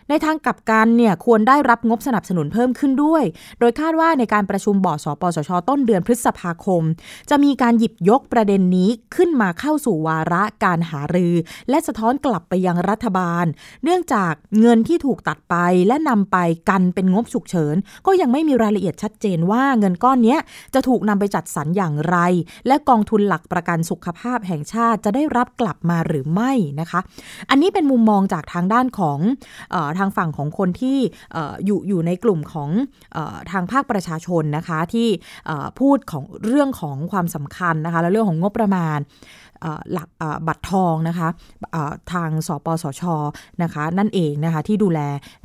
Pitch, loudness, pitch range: 195 Hz, -19 LUFS, 170-235 Hz